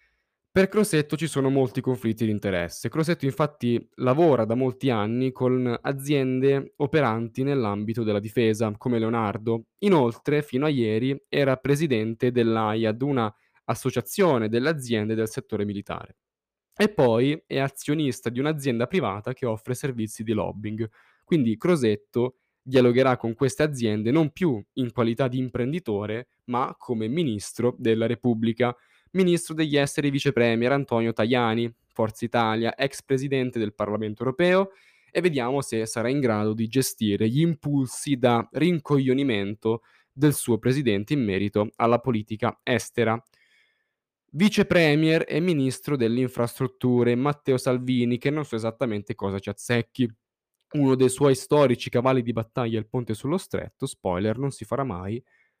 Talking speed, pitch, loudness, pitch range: 140 wpm, 125 Hz, -25 LUFS, 115-140 Hz